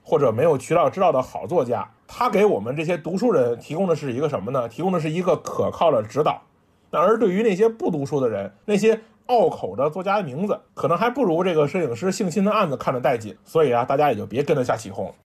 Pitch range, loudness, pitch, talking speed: 160-215 Hz, -22 LUFS, 190 Hz, 370 characters per minute